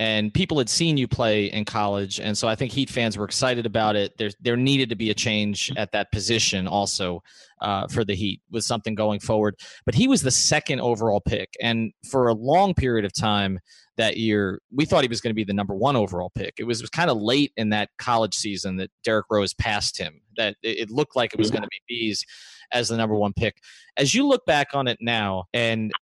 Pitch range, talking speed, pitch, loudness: 105-120 Hz, 240 wpm, 110 Hz, -23 LUFS